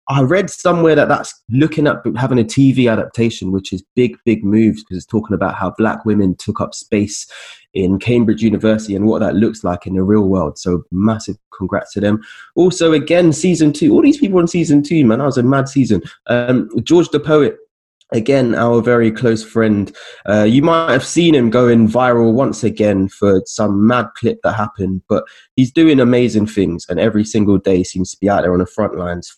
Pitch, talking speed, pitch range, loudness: 115 Hz, 210 wpm, 100-135 Hz, -14 LUFS